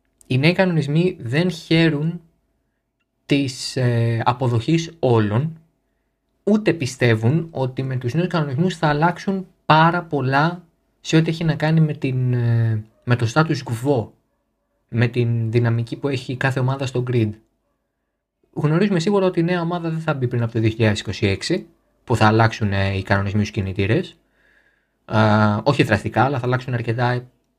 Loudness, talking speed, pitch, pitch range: -20 LUFS, 140 wpm, 130 Hz, 115-160 Hz